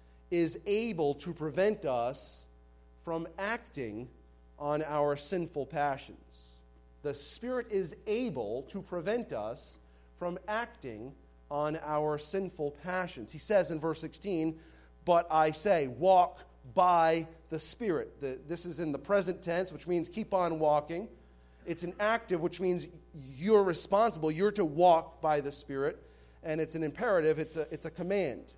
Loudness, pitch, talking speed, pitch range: -32 LUFS, 160 Hz, 145 wpm, 145-185 Hz